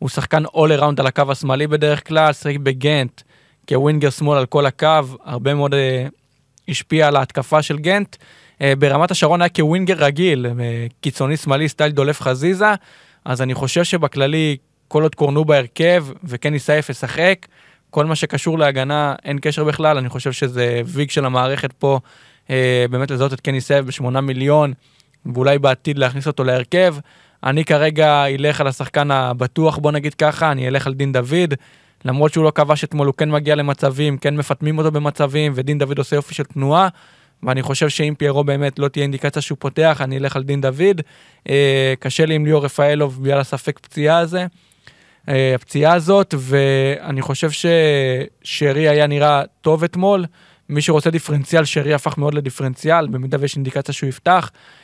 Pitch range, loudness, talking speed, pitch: 135-155 Hz, -17 LUFS, 160 wpm, 145 Hz